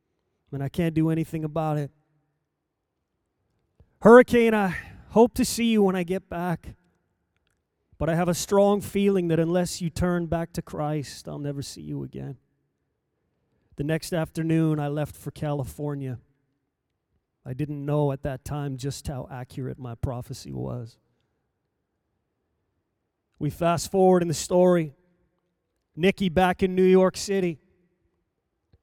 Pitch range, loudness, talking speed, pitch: 125-180 Hz, -24 LUFS, 140 wpm, 150 Hz